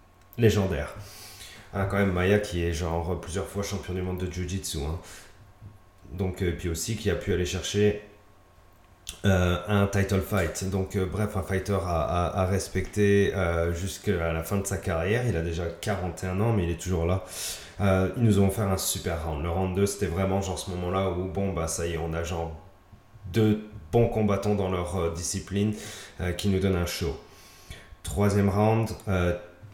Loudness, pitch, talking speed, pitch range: -27 LUFS, 95 Hz, 195 wpm, 90-100 Hz